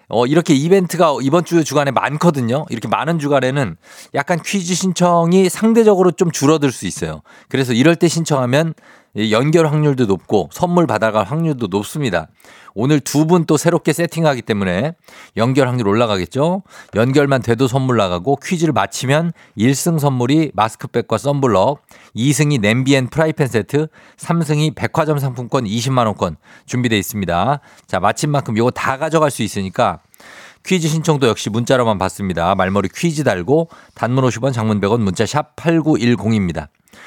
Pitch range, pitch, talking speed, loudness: 115-160 Hz, 140 Hz, 340 characters per minute, -16 LUFS